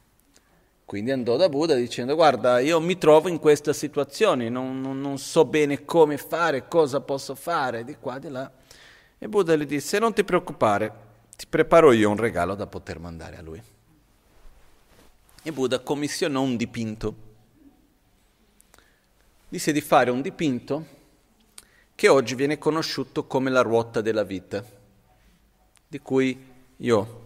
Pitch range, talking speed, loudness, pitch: 115-155 Hz, 145 wpm, -23 LUFS, 135 Hz